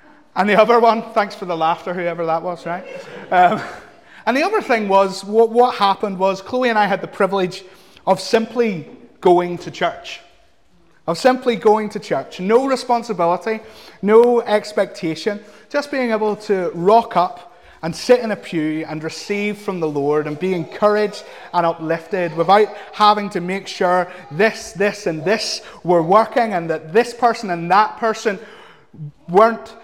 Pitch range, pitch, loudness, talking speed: 175-225 Hz, 205 Hz, -18 LUFS, 165 wpm